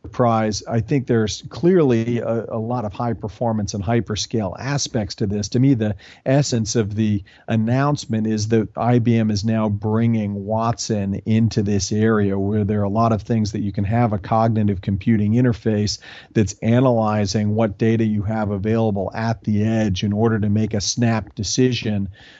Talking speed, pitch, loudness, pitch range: 170 wpm, 110 Hz, -20 LUFS, 105-115 Hz